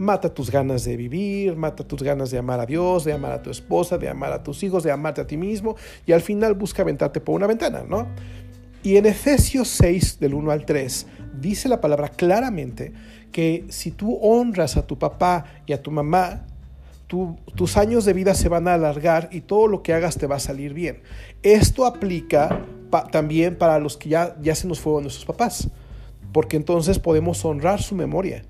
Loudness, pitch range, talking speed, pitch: -21 LUFS, 145-185 Hz, 205 wpm, 160 Hz